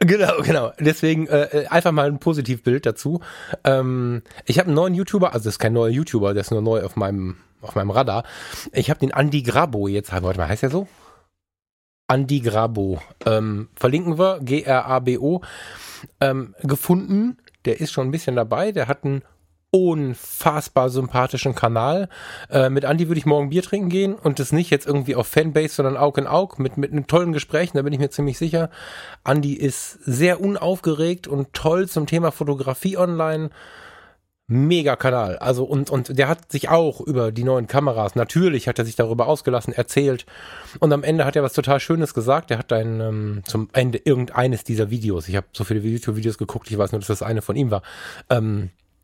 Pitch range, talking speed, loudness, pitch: 115-155 Hz, 195 wpm, -21 LUFS, 135 Hz